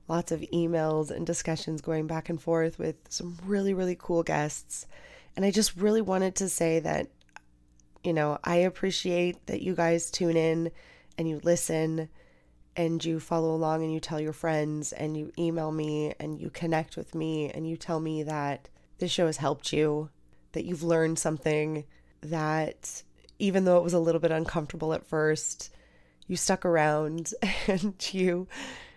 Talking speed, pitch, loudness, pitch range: 170 wpm, 165 Hz, -29 LUFS, 155-175 Hz